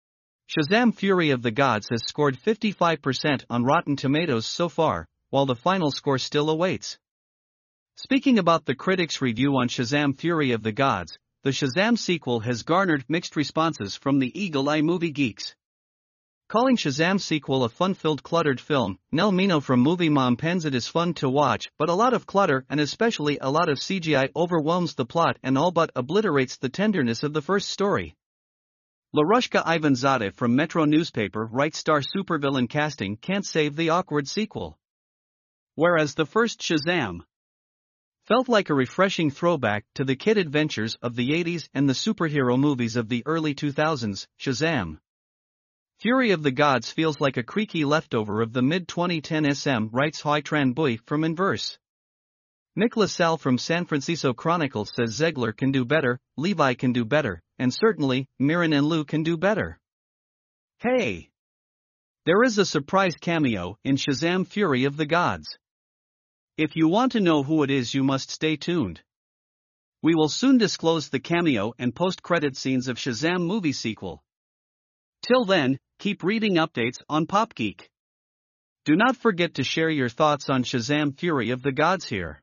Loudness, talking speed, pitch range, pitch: -24 LUFS, 165 wpm, 130-170 Hz, 150 Hz